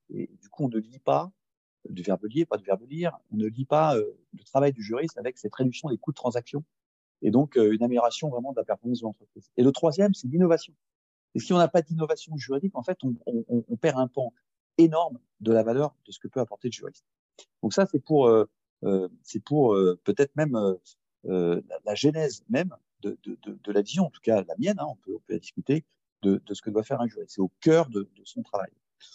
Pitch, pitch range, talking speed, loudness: 135 Hz, 110-160 Hz, 250 wpm, -27 LUFS